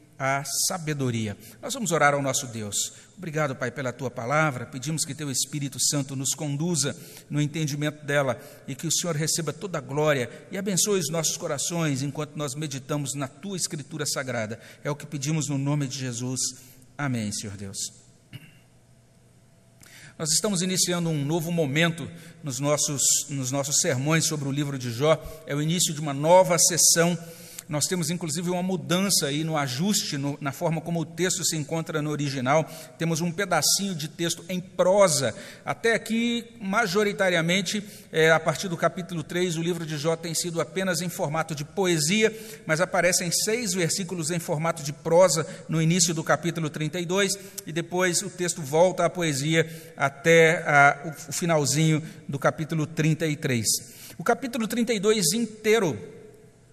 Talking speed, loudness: 160 wpm, -25 LUFS